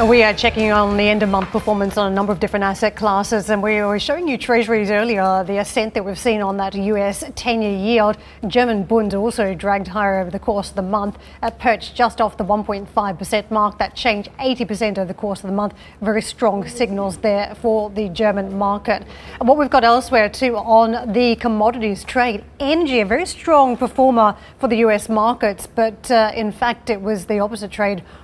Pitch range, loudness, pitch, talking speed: 205-230 Hz, -18 LUFS, 215 Hz, 200 wpm